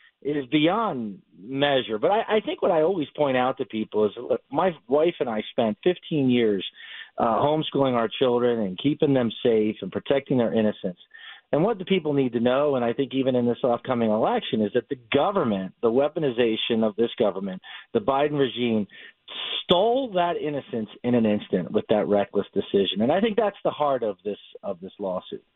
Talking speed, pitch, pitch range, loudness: 195 wpm, 130 Hz, 110-150 Hz, -24 LUFS